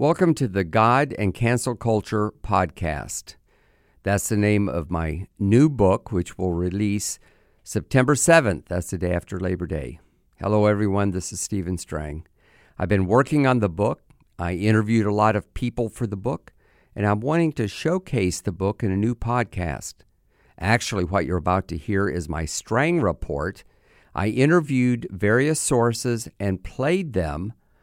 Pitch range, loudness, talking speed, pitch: 90-120 Hz, -23 LUFS, 160 wpm, 105 Hz